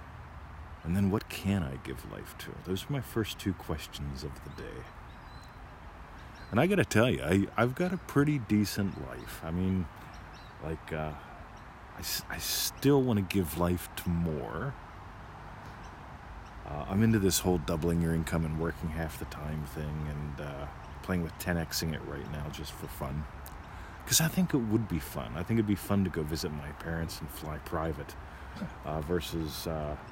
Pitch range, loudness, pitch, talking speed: 75-100 Hz, -32 LUFS, 85 Hz, 175 wpm